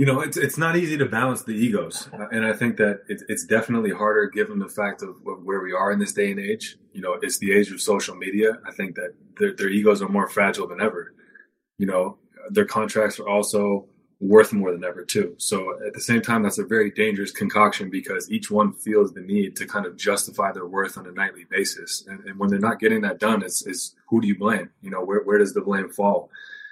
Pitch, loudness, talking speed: 125 Hz, -23 LUFS, 240 wpm